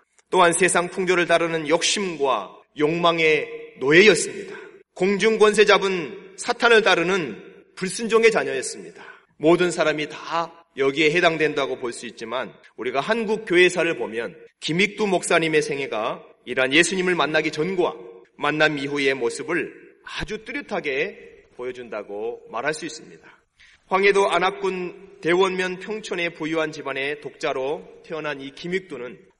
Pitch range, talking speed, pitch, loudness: 155-220 Hz, 305 characters per minute, 180 Hz, -21 LUFS